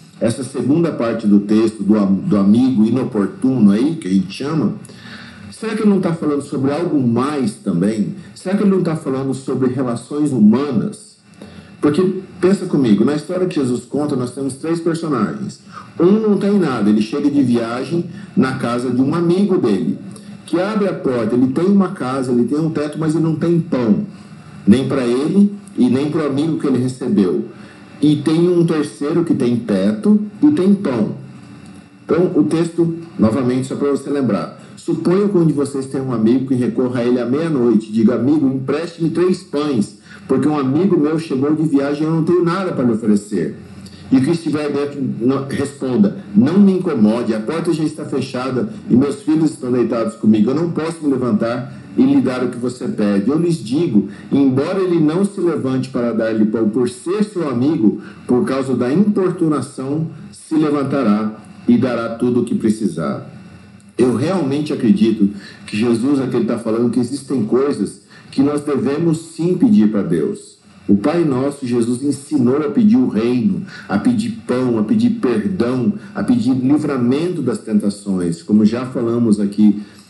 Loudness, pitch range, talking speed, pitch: -17 LUFS, 120-175 Hz, 180 wpm, 145 Hz